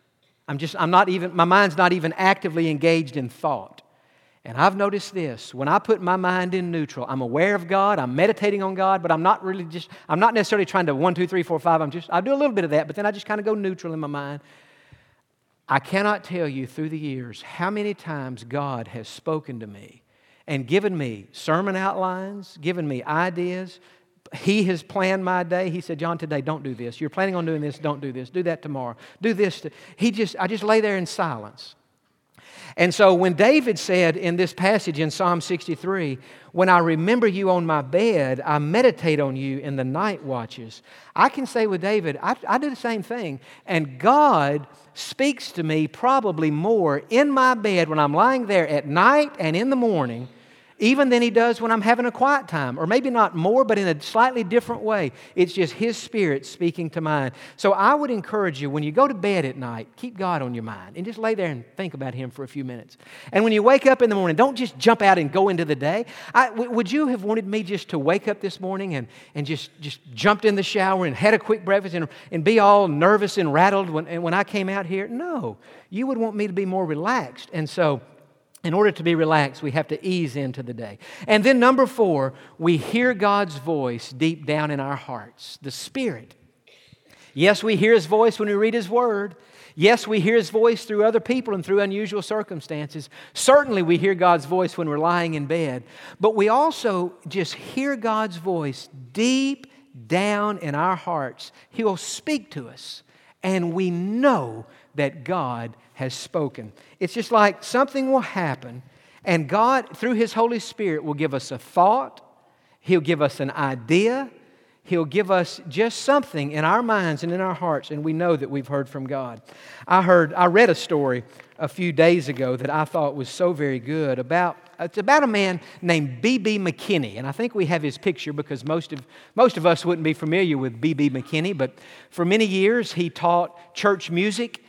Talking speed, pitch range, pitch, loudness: 215 wpm, 150-210 Hz, 180 Hz, -22 LUFS